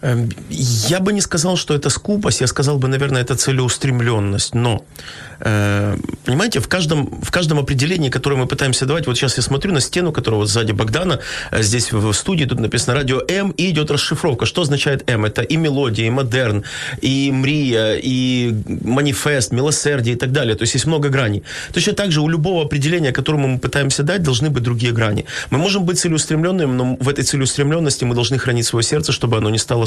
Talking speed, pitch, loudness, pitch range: 195 wpm, 135 Hz, -17 LUFS, 120-150 Hz